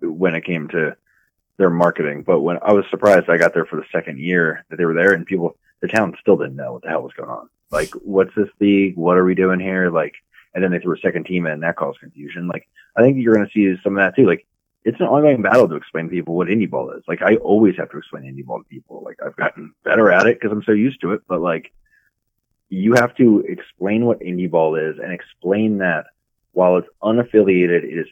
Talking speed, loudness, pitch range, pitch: 260 wpm, -17 LUFS, 85-100 Hz, 90 Hz